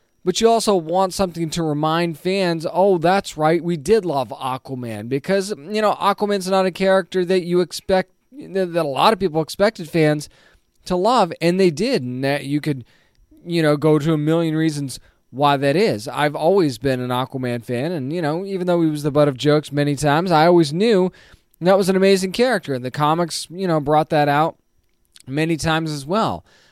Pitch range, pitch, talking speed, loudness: 145-190 Hz, 165 Hz, 200 wpm, -19 LUFS